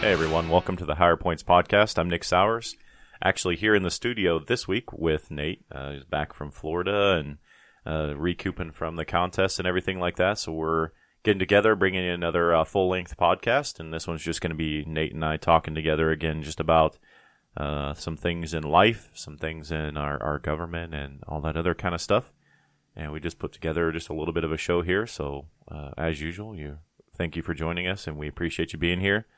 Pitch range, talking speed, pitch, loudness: 80-90 Hz, 220 wpm, 85 Hz, -26 LUFS